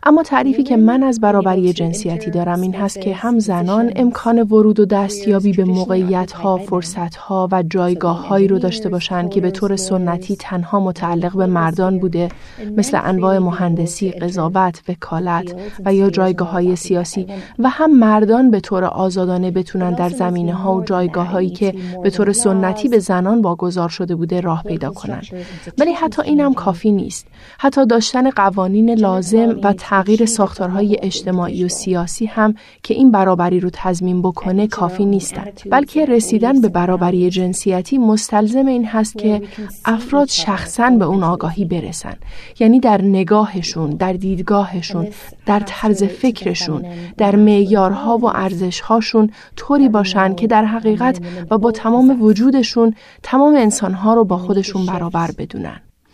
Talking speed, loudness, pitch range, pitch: 150 wpm, -15 LUFS, 180-220 Hz, 195 Hz